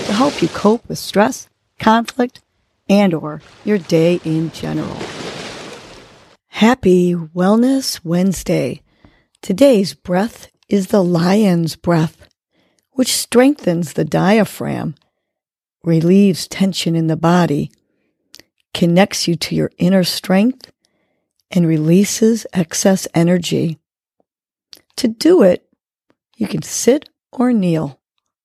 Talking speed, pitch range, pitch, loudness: 105 wpm, 170-220 Hz, 185 Hz, -15 LUFS